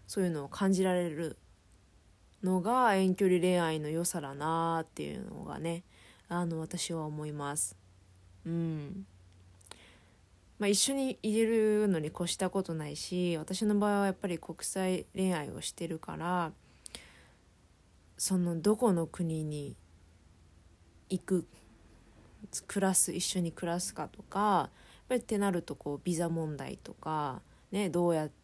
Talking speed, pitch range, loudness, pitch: 255 characters per minute, 140-185 Hz, -32 LUFS, 165 Hz